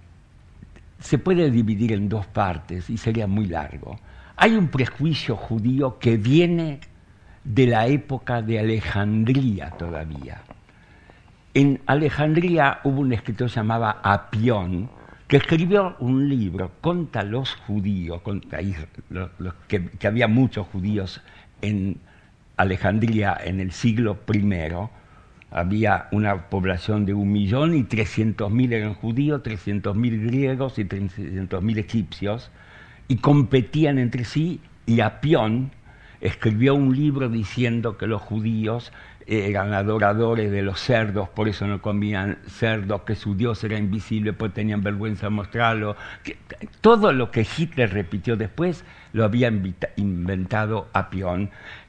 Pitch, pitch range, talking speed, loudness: 110 Hz, 100-125 Hz, 125 wpm, -23 LUFS